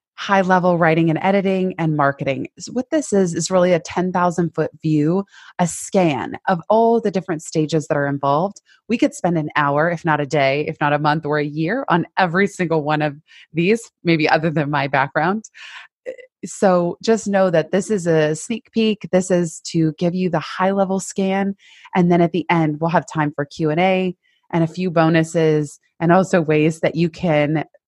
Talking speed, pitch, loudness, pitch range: 200 wpm, 170 Hz, -19 LUFS, 155-190 Hz